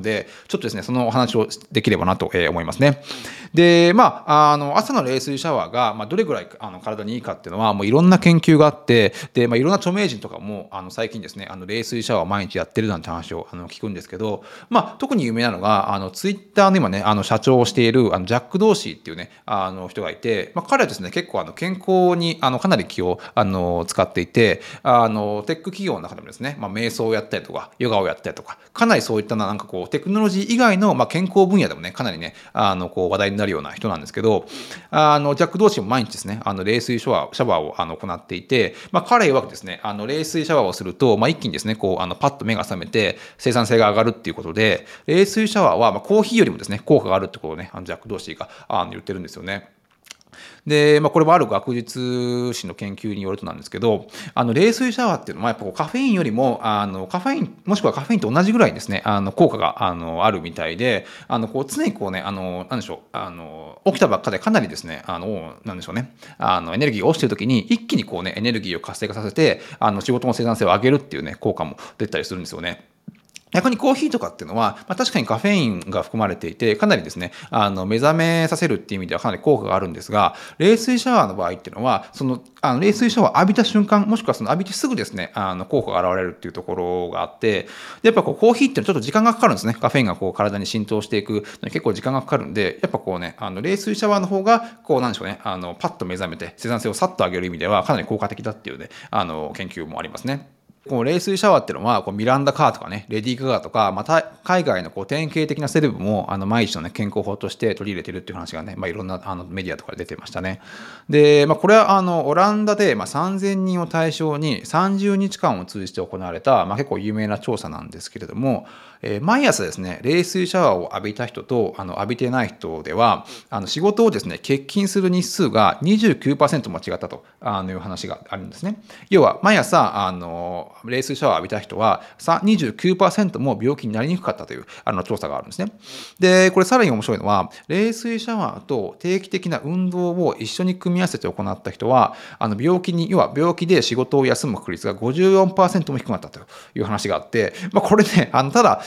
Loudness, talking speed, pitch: -20 LUFS, 465 characters per minute, 135 Hz